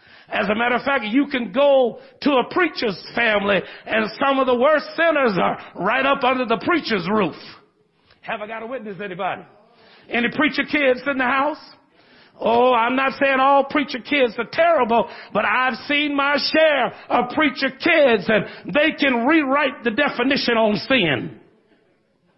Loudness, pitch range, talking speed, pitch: -19 LUFS, 230-285 Hz, 165 wpm, 255 Hz